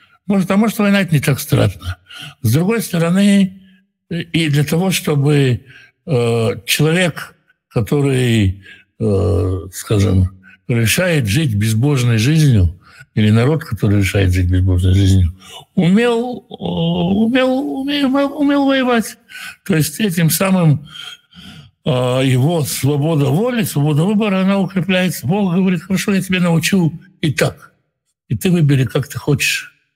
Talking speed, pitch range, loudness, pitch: 130 wpm, 120-195 Hz, -15 LUFS, 155 Hz